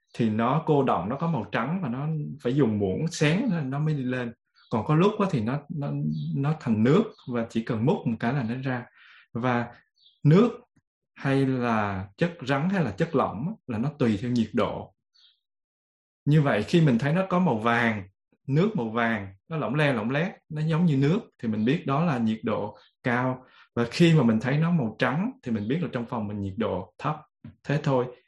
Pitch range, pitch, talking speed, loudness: 115-155 Hz, 130 Hz, 215 wpm, -26 LUFS